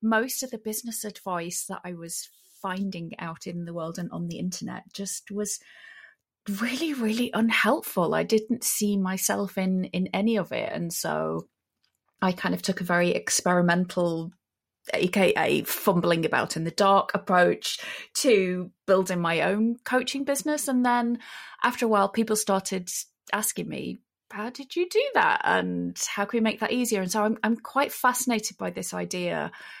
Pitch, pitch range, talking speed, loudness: 200 Hz, 180-230 Hz, 165 wpm, -26 LUFS